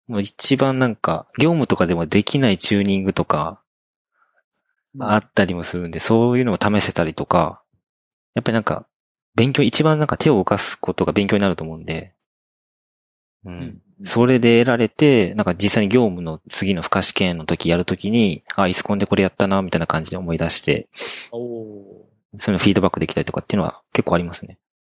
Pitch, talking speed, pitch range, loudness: 100 Hz, 385 characters per minute, 85-115 Hz, -19 LUFS